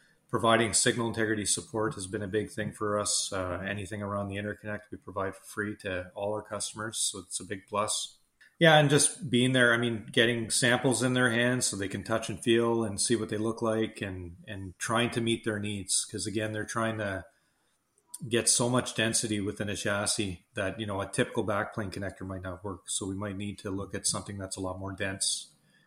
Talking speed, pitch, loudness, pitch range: 220 wpm, 105 Hz, -29 LUFS, 100-115 Hz